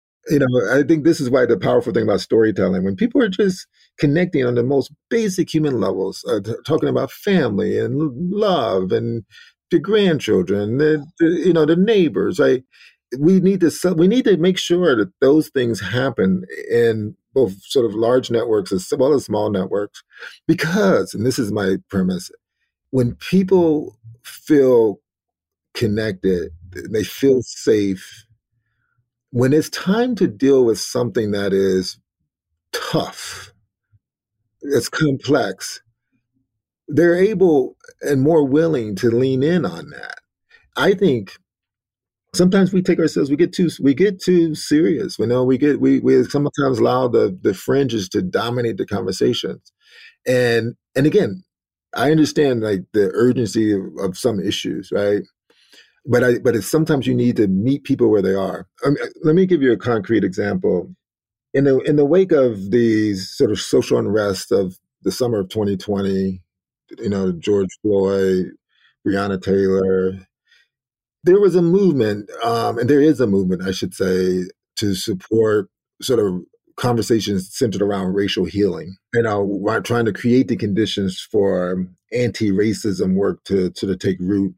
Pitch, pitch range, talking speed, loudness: 120 Hz, 100-155 Hz, 155 wpm, -18 LUFS